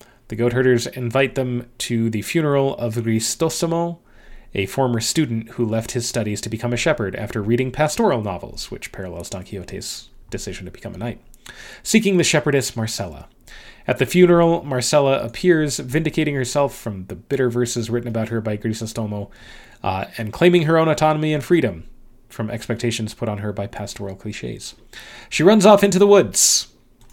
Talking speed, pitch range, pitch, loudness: 170 wpm, 110-150 Hz, 120 Hz, -19 LUFS